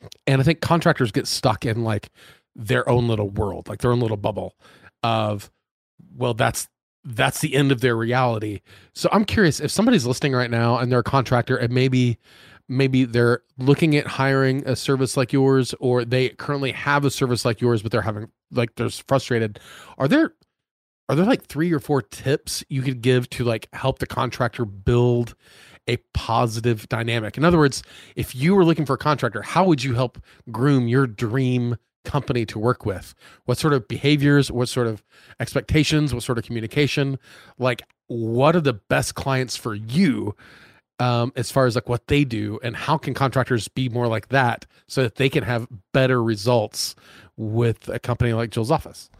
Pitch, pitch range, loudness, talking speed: 125 Hz, 115-135 Hz, -21 LUFS, 190 wpm